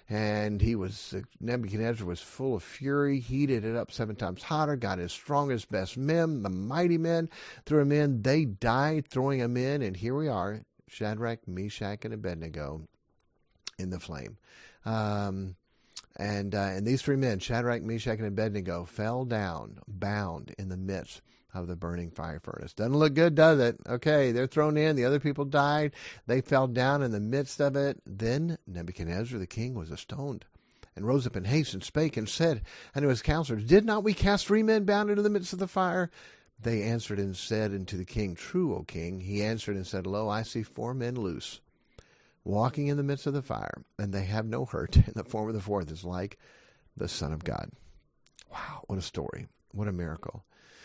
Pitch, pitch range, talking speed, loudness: 115 Hz, 100-140 Hz, 195 wpm, -30 LUFS